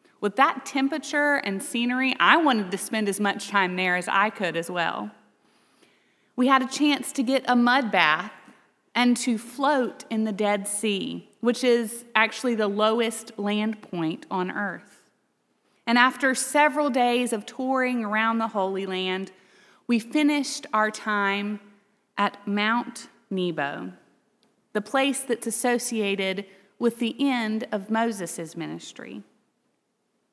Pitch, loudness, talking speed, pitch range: 225 Hz, -24 LUFS, 140 wpm, 200-250 Hz